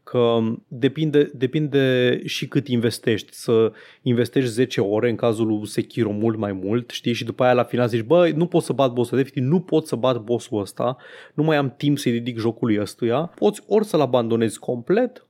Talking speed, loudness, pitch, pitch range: 200 wpm, -21 LUFS, 125 Hz, 115-145 Hz